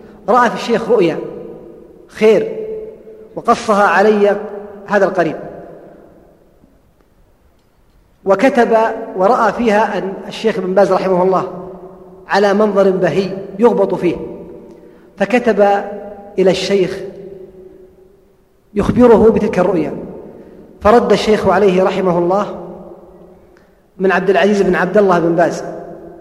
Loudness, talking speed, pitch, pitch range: -13 LUFS, 95 wpm, 195 Hz, 185-215 Hz